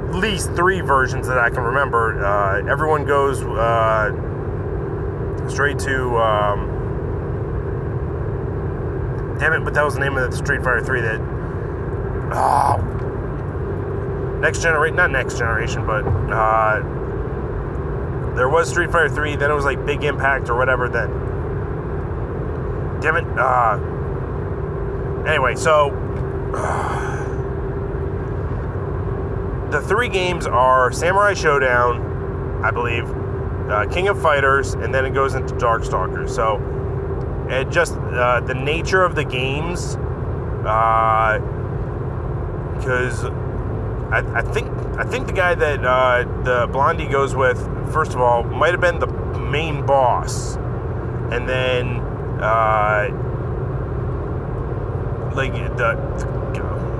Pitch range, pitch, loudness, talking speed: 115-130 Hz, 125 Hz, -20 LUFS, 120 wpm